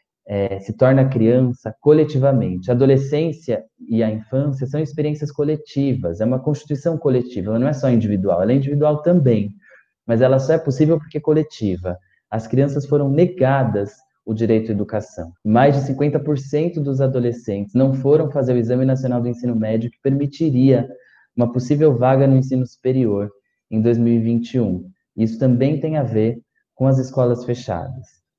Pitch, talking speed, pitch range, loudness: 130 Hz, 160 wpm, 115-145 Hz, -18 LUFS